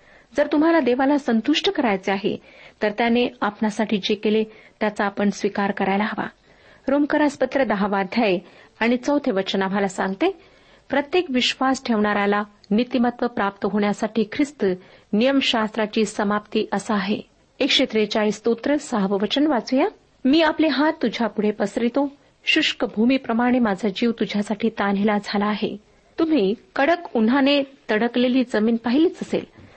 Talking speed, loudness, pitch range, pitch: 125 wpm, -21 LUFS, 210-270 Hz, 225 Hz